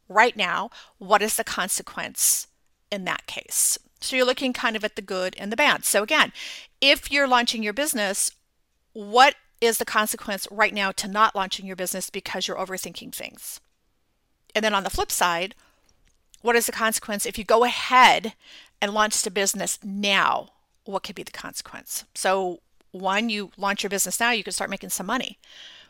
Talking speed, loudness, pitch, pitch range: 185 wpm, -23 LUFS, 215 Hz, 195-235 Hz